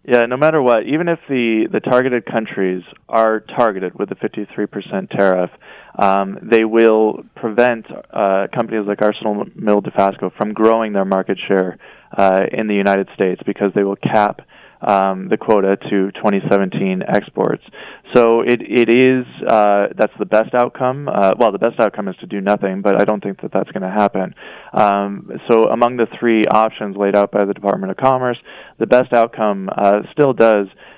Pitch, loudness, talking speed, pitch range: 105 Hz, -16 LUFS, 180 wpm, 100-115 Hz